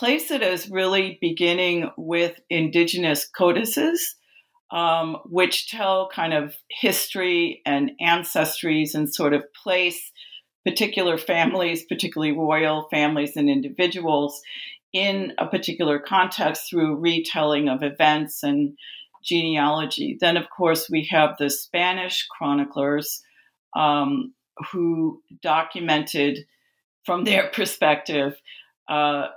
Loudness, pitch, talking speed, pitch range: -22 LUFS, 165 Hz, 105 wpm, 150-180 Hz